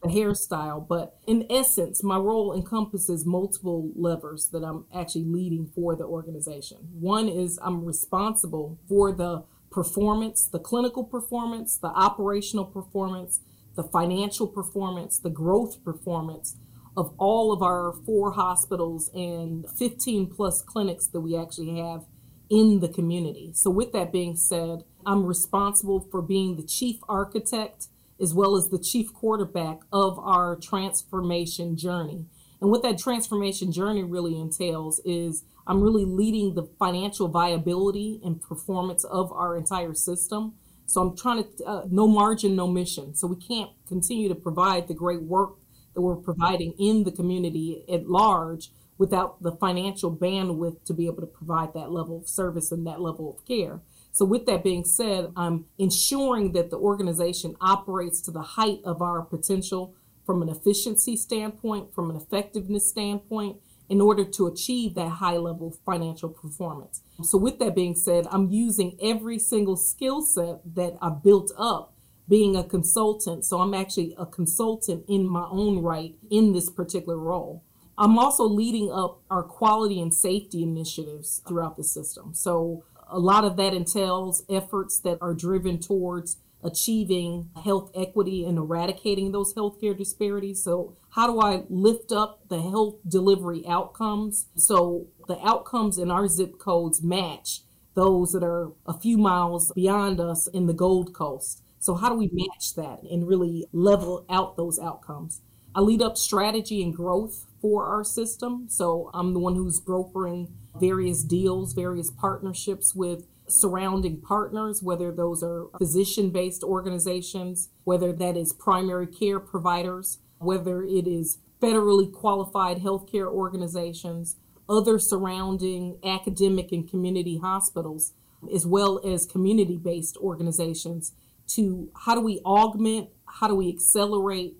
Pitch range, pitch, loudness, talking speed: 170-200 Hz, 185 Hz, -25 LUFS, 150 wpm